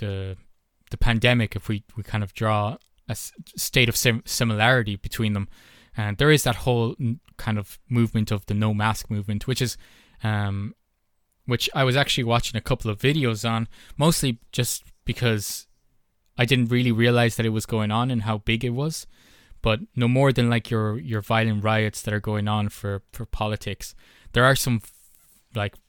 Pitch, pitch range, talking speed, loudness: 110 Hz, 105-120 Hz, 190 wpm, -24 LUFS